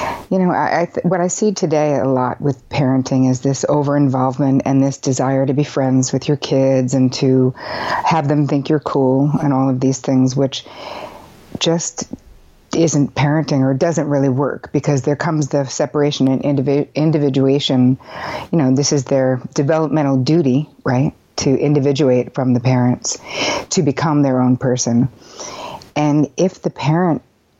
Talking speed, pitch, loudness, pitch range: 165 wpm, 140 Hz, -16 LUFS, 130-150 Hz